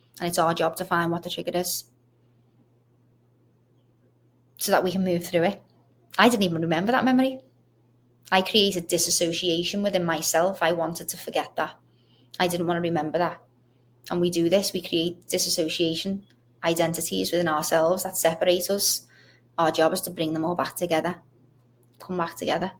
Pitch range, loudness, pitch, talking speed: 125-180 Hz, -25 LUFS, 165 Hz, 170 wpm